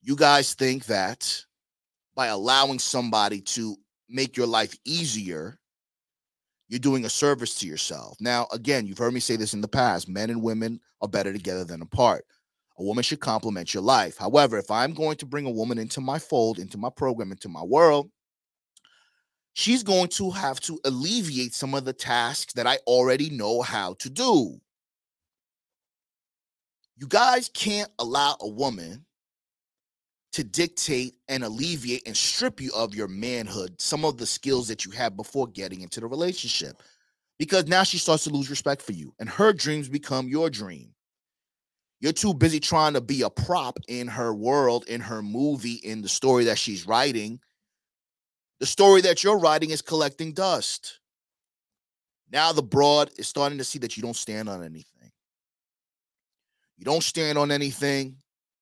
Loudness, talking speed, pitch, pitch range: -24 LUFS, 170 wpm, 130 Hz, 115-150 Hz